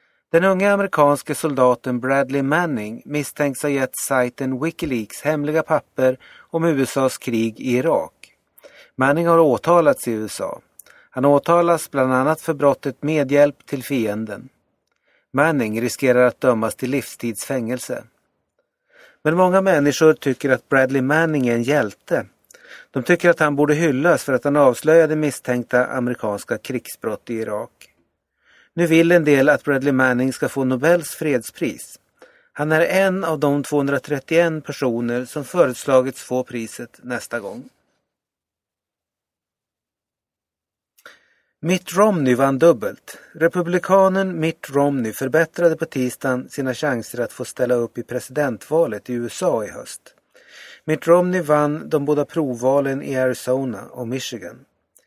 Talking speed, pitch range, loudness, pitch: 130 wpm, 125-160 Hz, -19 LUFS, 140 Hz